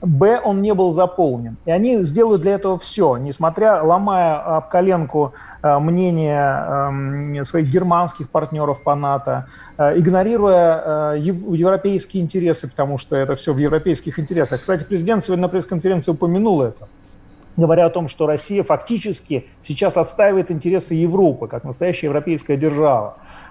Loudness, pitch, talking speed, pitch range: -18 LUFS, 165 Hz, 135 wpm, 145-185 Hz